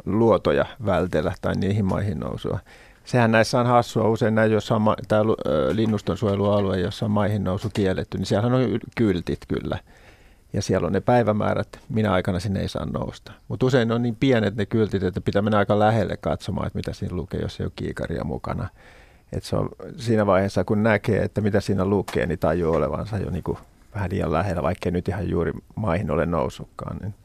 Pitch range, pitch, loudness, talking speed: 95-110 Hz, 105 Hz, -23 LUFS, 190 wpm